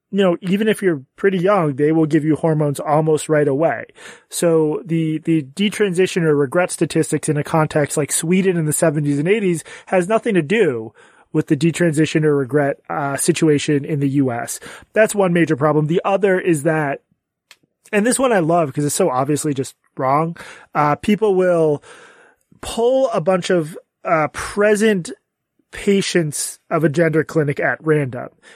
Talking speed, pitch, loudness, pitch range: 170 wpm, 165 Hz, -18 LUFS, 150-190 Hz